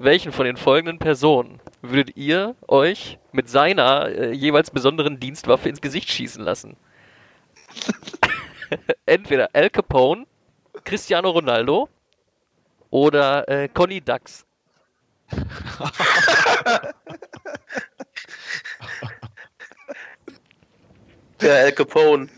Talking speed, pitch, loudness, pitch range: 80 wpm, 150 Hz, -19 LUFS, 140-175 Hz